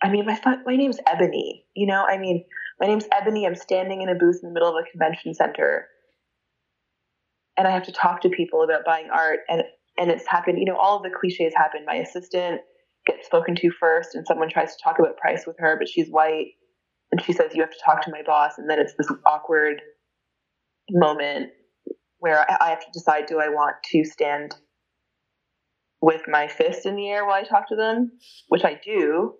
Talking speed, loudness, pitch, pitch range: 210 wpm, -22 LUFS, 185 Hz, 160-255 Hz